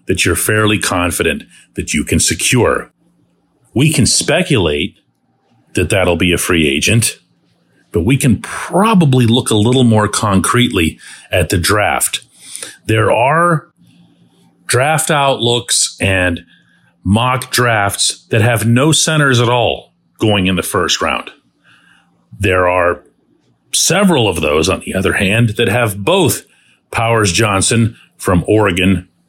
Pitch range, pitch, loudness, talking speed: 95-125 Hz, 115 Hz, -13 LUFS, 130 wpm